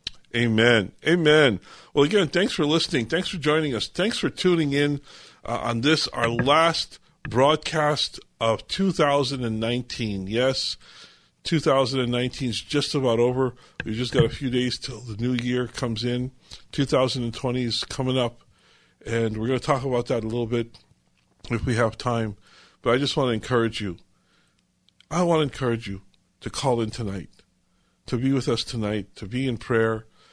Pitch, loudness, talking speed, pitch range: 125 Hz, -24 LUFS, 165 wpm, 115-140 Hz